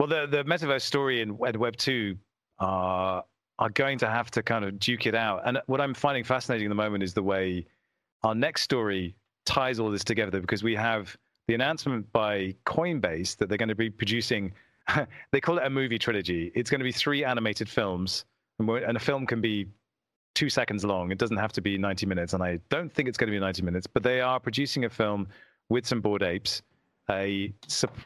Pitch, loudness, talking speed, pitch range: 110 Hz, -28 LUFS, 220 wpm, 100-125 Hz